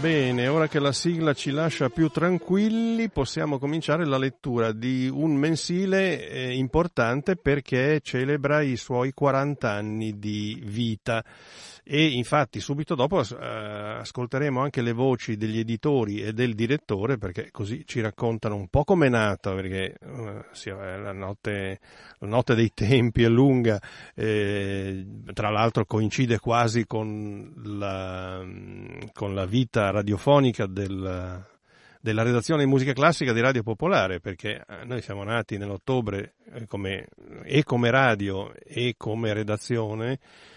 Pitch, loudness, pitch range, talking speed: 120 Hz, -25 LUFS, 105-140 Hz, 130 wpm